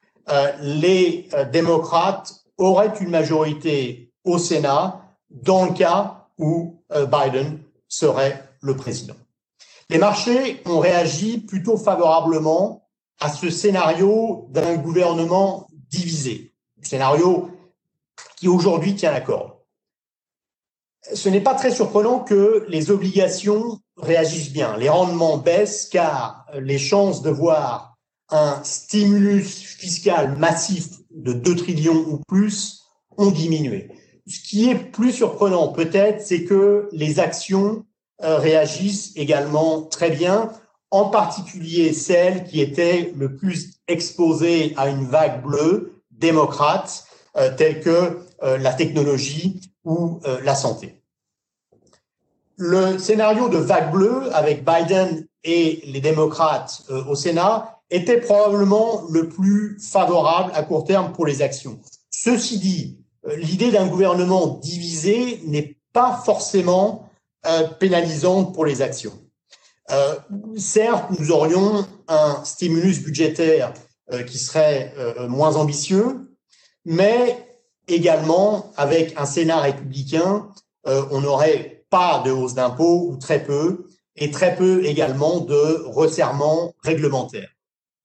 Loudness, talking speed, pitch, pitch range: -19 LUFS, 110 wpm, 170 Hz, 155-200 Hz